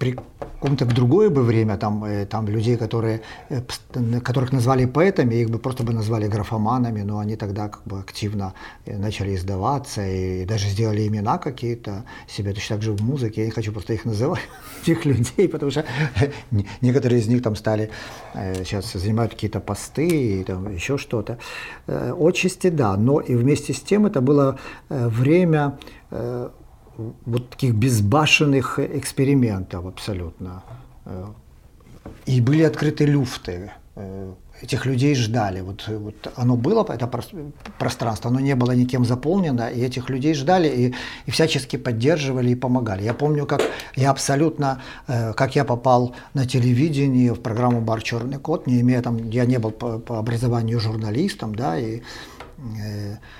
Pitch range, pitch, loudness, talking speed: 110-135 Hz, 120 Hz, -22 LUFS, 145 wpm